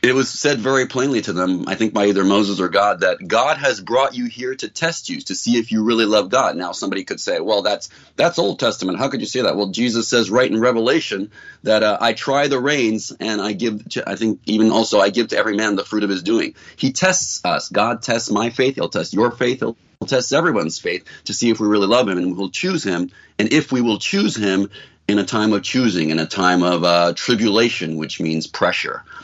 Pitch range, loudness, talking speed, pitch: 100-125 Hz, -18 LUFS, 250 wpm, 110 Hz